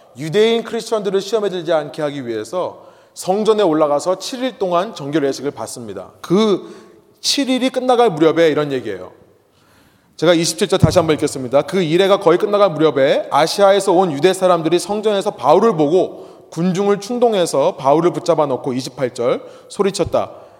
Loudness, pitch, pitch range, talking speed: -16 LUFS, 180 Hz, 155-205 Hz, 350 characters per minute